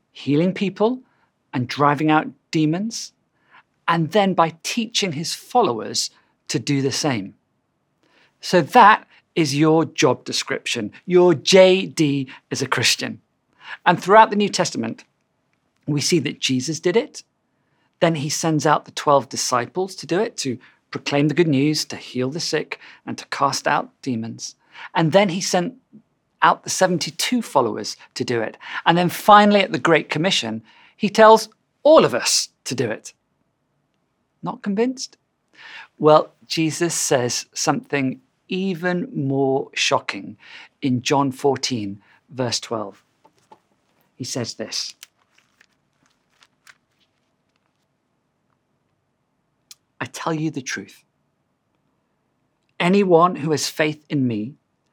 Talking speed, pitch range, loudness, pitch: 125 wpm, 140-190 Hz, -19 LUFS, 160 Hz